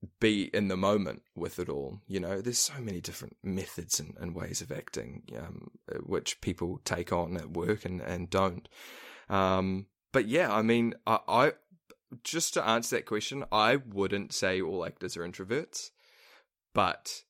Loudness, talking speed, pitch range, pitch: -31 LUFS, 170 wpm, 95-115 Hz, 100 Hz